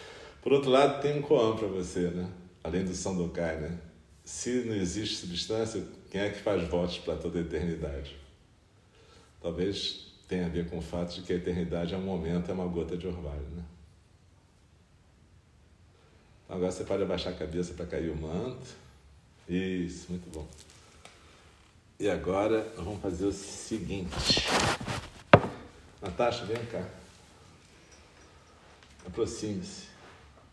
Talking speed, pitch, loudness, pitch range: 140 wpm, 90 Hz, -31 LUFS, 85-95 Hz